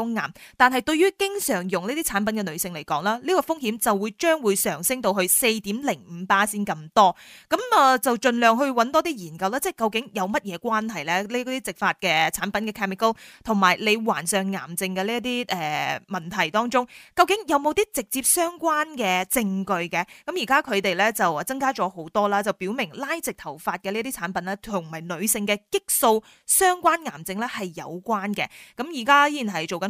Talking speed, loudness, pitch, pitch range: 315 characters per minute, -23 LUFS, 215 Hz, 190-260 Hz